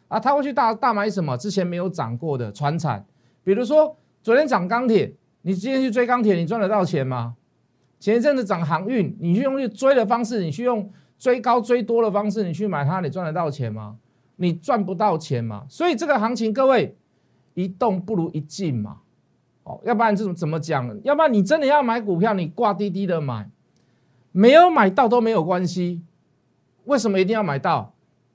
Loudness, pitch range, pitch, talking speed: -21 LUFS, 160-240 Hz, 195 Hz, 290 characters per minute